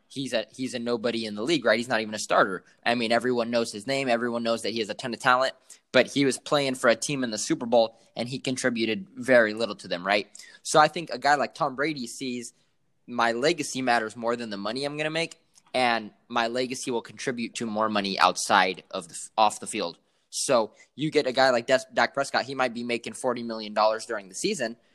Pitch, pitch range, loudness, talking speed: 120 Hz, 115-135 Hz, -26 LUFS, 245 wpm